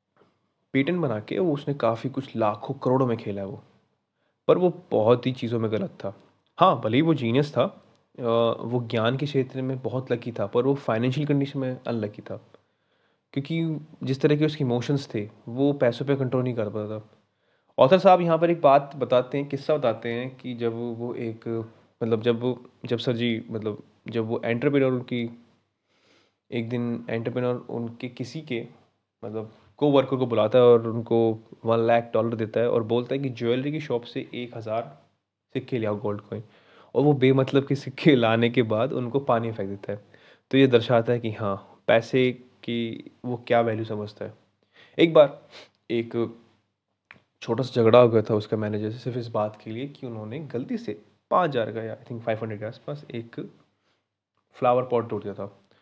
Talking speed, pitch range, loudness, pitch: 190 wpm, 110-130 Hz, -25 LUFS, 120 Hz